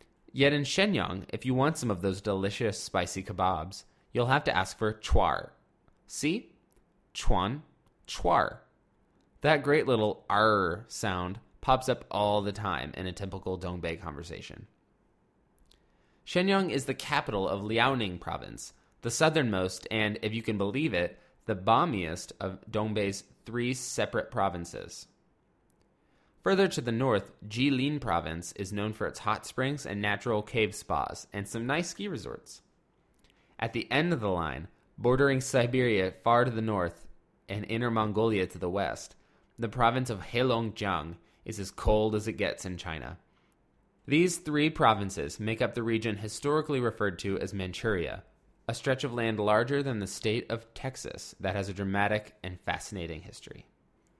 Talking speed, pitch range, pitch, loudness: 155 wpm, 95-125 Hz, 110 Hz, -30 LUFS